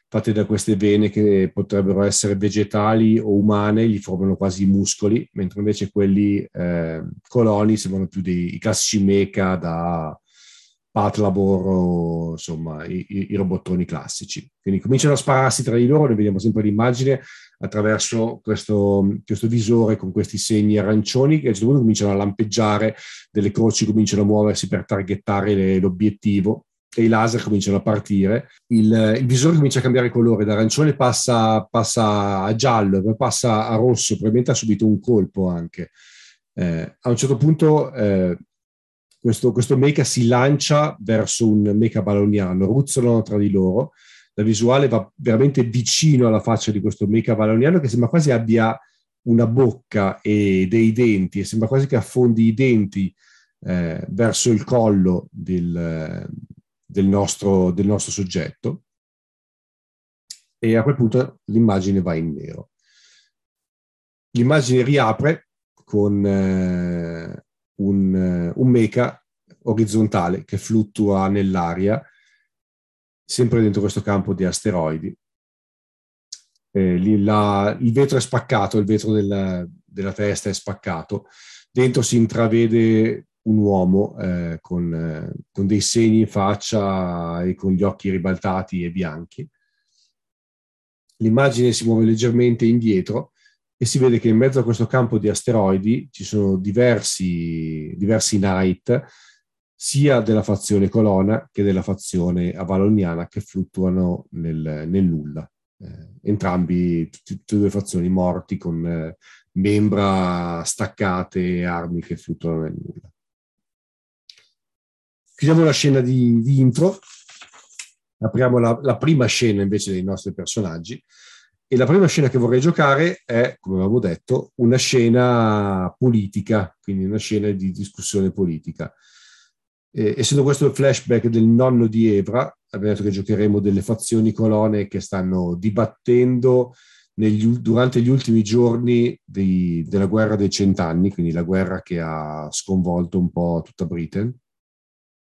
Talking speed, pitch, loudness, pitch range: 140 wpm, 105 Hz, -19 LUFS, 95-120 Hz